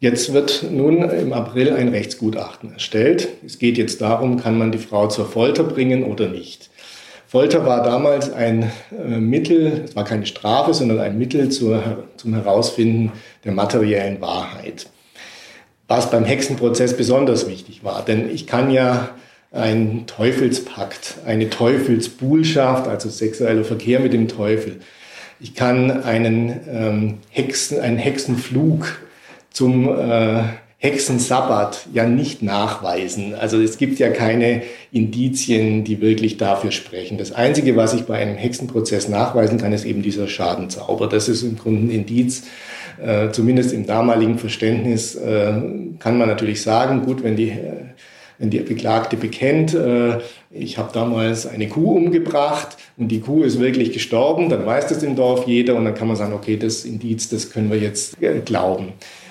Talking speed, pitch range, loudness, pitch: 155 wpm, 110-125 Hz, -18 LUFS, 115 Hz